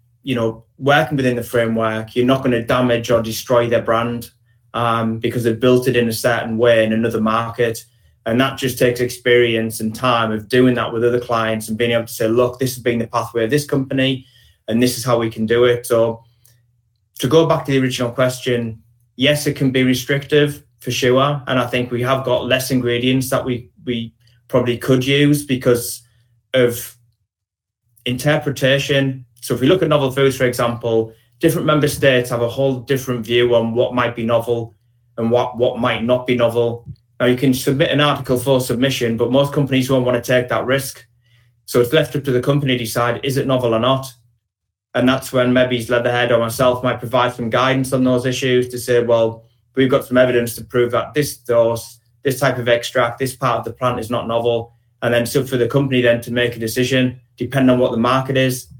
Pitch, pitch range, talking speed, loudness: 125 Hz, 115-130 Hz, 215 wpm, -17 LUFS